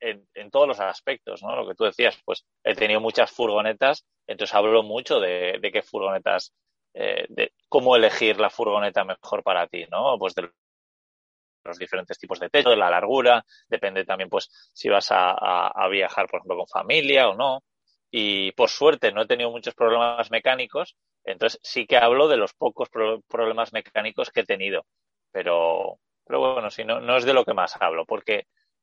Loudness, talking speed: -23 LUFS, 190 wpm